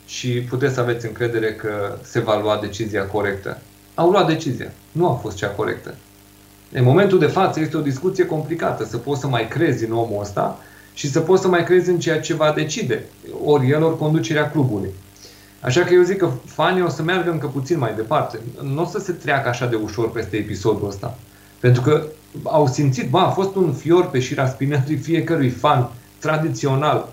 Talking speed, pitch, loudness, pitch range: 200 wpm, 135 Hz, -20 LUFS, 110-160 Hz